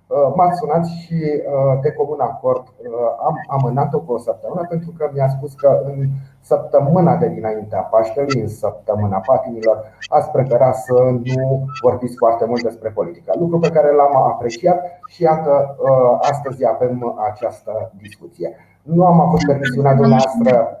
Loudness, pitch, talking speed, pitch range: -17 LUFS, 135 Hz, 140 wpm, 125-155 Hz